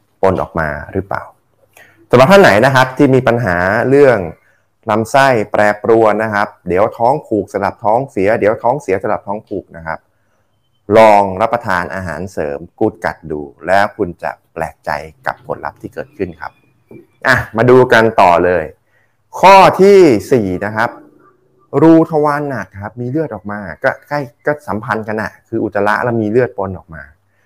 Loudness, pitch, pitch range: -12 LUFS, 105 Hz, 95-125 Hz